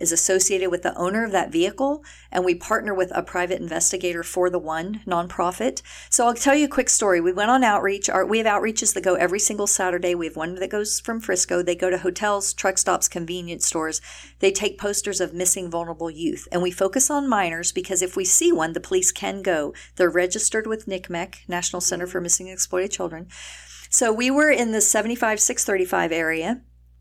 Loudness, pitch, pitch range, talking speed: -21 LUFS, 185 Hz, 180-215 Hz, 210 wpm